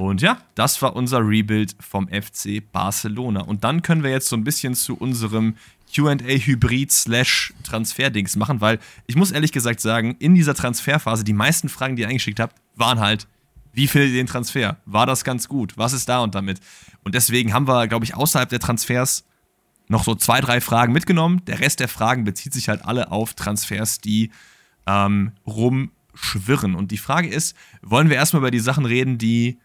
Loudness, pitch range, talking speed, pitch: -20 LUFS, 110-135 Hz, 190 wpm, 120 Hz